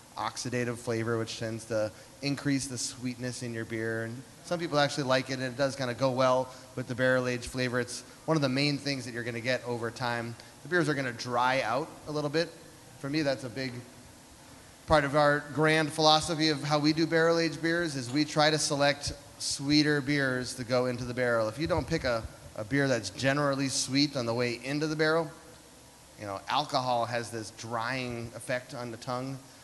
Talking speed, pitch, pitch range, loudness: 215 wpm, 130 Hz, 120-145 Hz, -30 LUFS